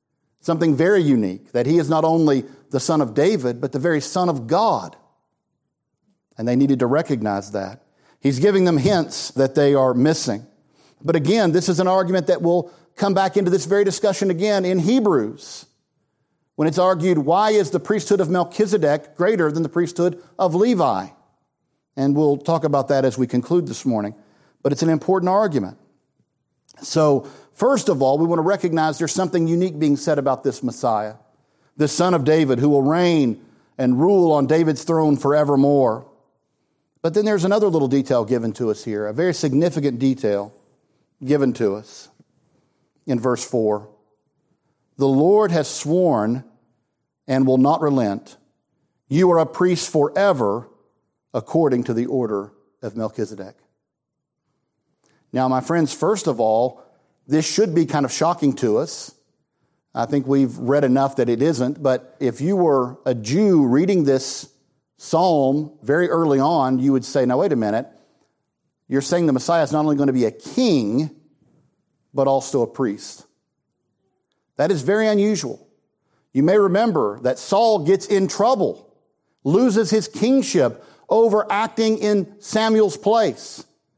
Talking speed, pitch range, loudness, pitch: 160 wpm, 135-180 Hz, -19 LUFS, 150 Hz